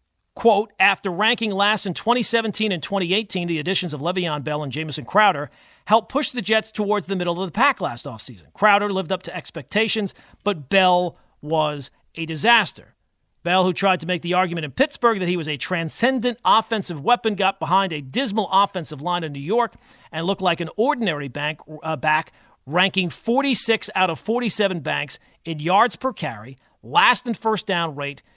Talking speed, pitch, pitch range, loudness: 180 wpm, 185 Hz, 160-215 Hz, -21 LUFS